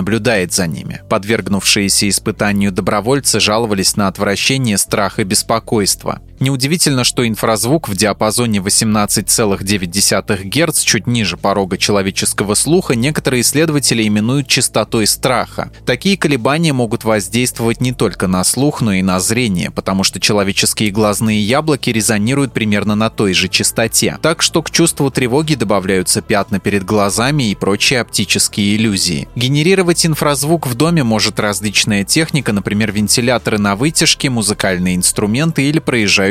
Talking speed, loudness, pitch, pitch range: 130 wpm, -13 LUFS, 110 Hz, 100-135 Hz